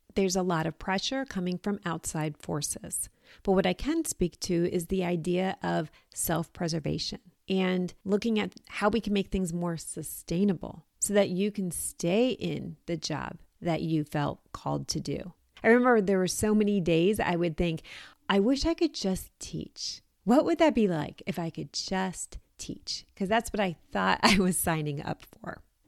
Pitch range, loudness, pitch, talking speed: 165-205 Hz, -29 LUFS, 185 Hz, 190 wpm